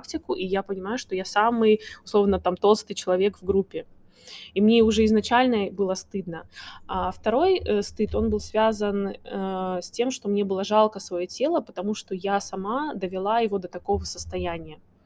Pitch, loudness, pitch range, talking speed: 200 Hz, -24 LUFS, 185-220 Hz, 175 wpm